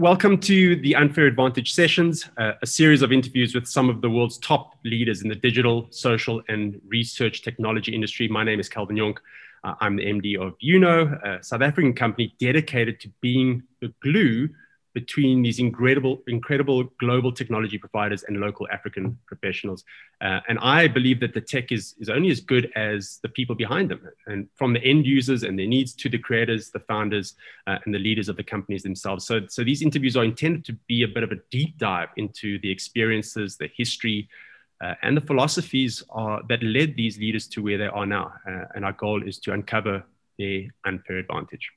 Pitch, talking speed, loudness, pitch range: 115 Hz, 200 wpm, -23 LUFS, 105-130 Hz